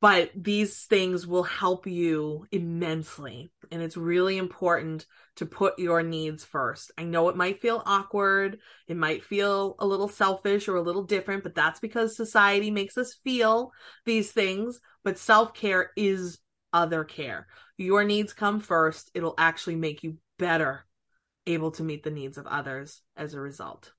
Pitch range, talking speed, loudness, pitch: 165-205 Hz, 165 wpm, -27 LUFS, 185 Hz